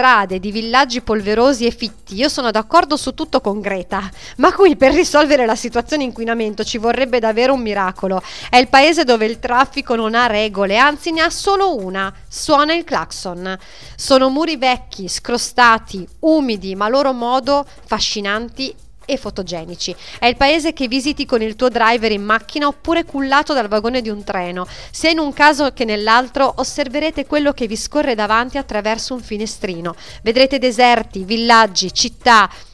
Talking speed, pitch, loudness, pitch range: 165 wpm, 245 Hz, -16 LUFS, 215-280 Hz